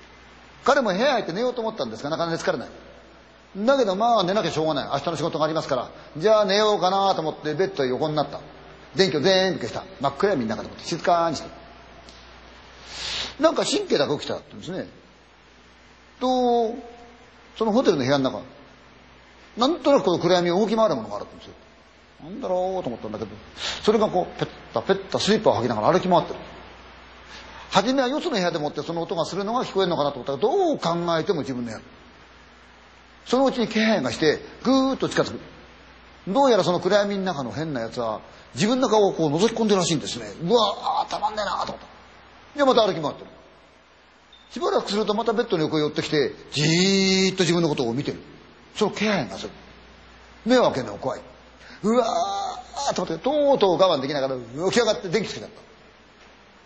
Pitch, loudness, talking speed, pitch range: 185 Hz, -23 LUFS, 415 characters per minute, 145-220 Hz